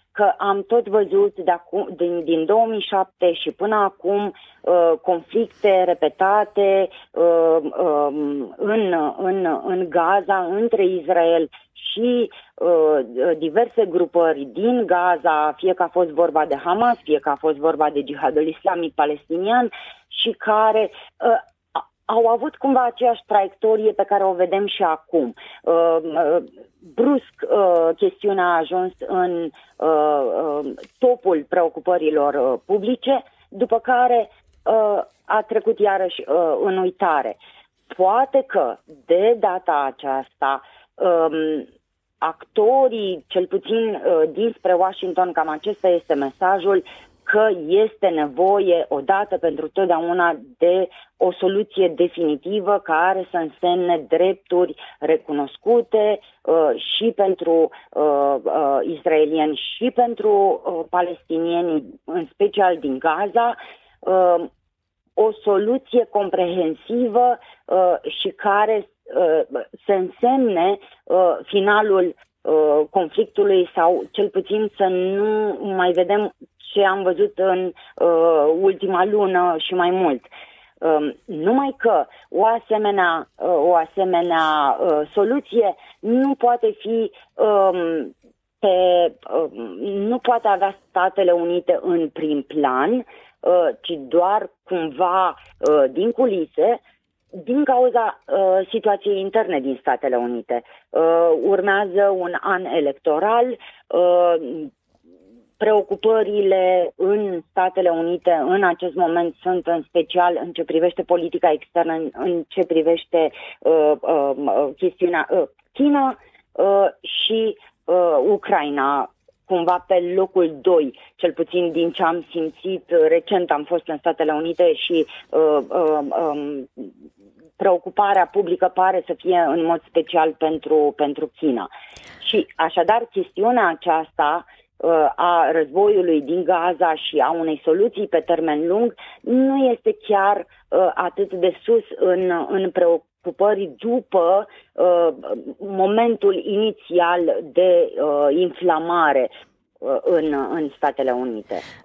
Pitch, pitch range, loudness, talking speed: 185 Hz, 165-215 Hz, -19 LUFS, 110 wpm